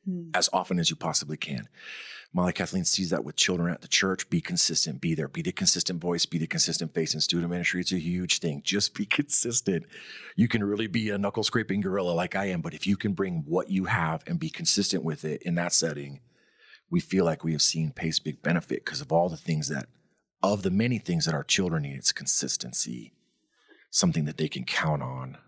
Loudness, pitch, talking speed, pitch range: -26 LUFS, 90 Hz, 225 wpm, 80-105 Hz